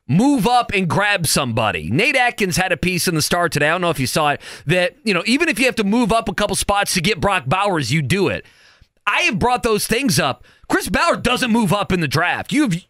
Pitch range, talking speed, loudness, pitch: 170-235 Hz, 260 wpm, -17 LUFS, 195 Hz